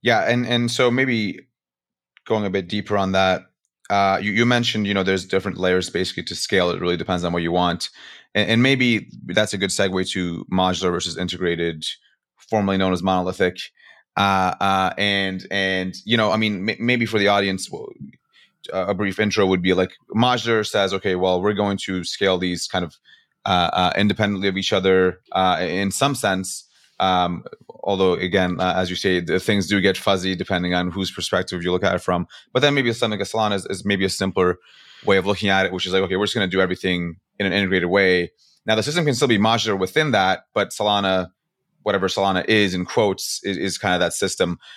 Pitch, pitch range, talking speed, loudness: 95 Hz, 90-105 Hz, 210 wpm, -20 LUFS